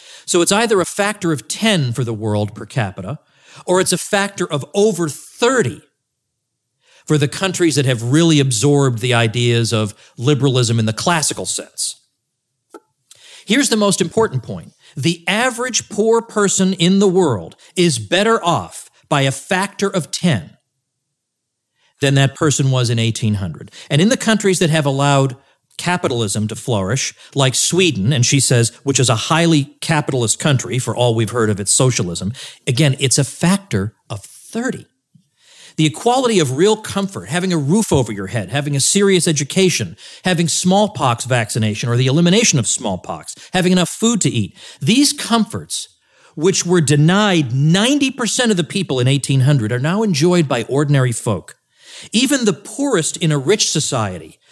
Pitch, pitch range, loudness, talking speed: 150 Hz, 125-185 Hz, -16 LUFS, 160 wpm